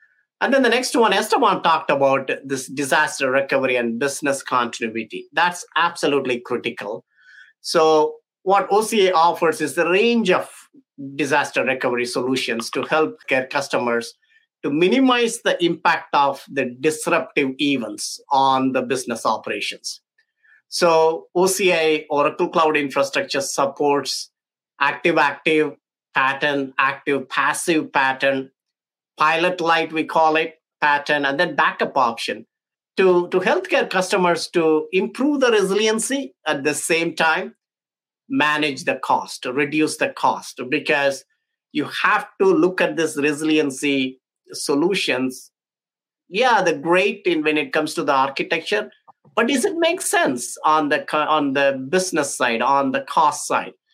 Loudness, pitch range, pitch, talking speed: -19 LUFS, 140-185 Hz, 155 Hz, 130 wpm